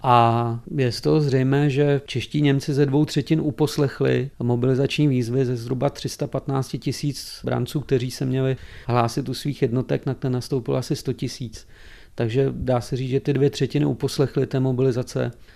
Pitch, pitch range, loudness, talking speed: 135 Hz, 125-145 Hz, -23 LUFS, 165 wpm